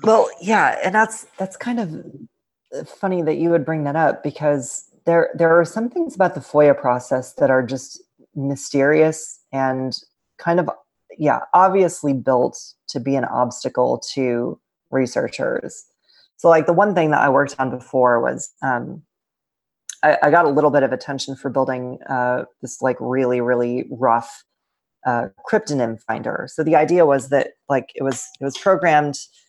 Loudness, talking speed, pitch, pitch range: -19 LUFS, 165 wpm, 140 Hz, 130-170 Hz